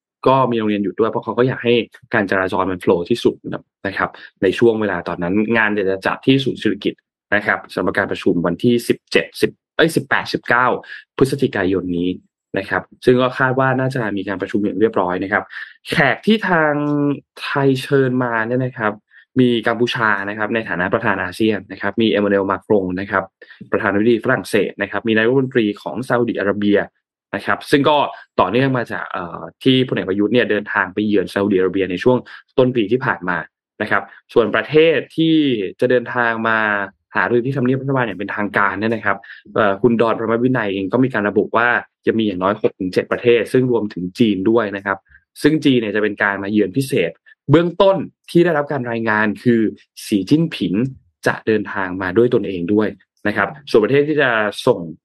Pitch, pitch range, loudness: 110 Hz, 100-125 Hz, -18 LUFS